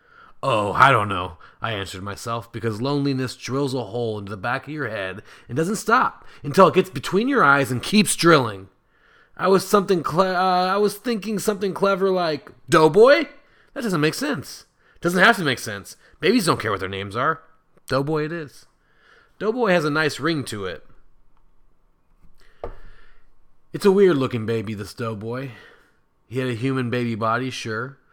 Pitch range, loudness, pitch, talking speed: 120-190 Hz, -21 LUFS, 145 Hz, 175 wpm